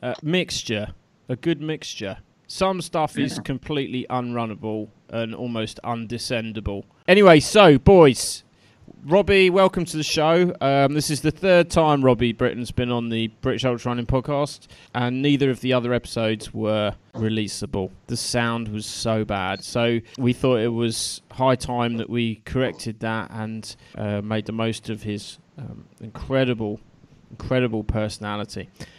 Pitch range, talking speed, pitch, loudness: 110-140 Hz, 145 wpm, 120 Hz, -22 LUFS